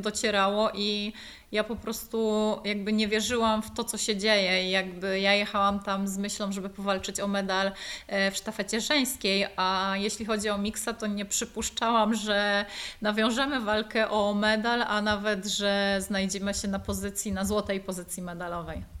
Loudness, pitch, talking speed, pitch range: -28 LUFS, 205 Hz, 160 wpm, 195-215 Hz